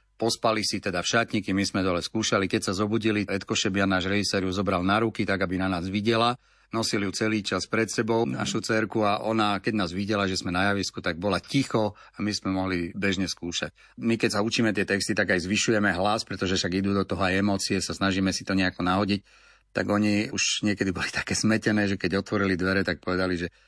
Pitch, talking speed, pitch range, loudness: 100 Hz, 220 wpm, 95-110 Hz, -26 LUFS